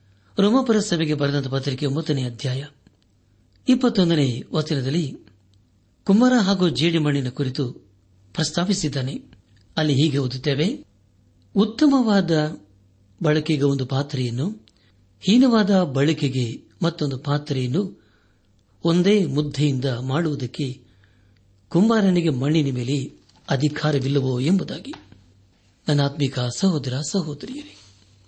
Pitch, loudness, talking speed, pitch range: 140 Hz, -22 LUFS, 75 wpm, 105-160 Hz